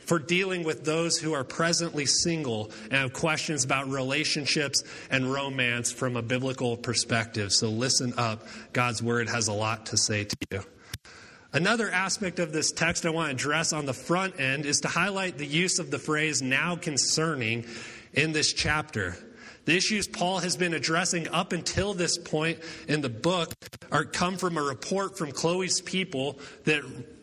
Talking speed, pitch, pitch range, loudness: 175 wpm, 150 Hz, 130-170 Hz, -27 LUFS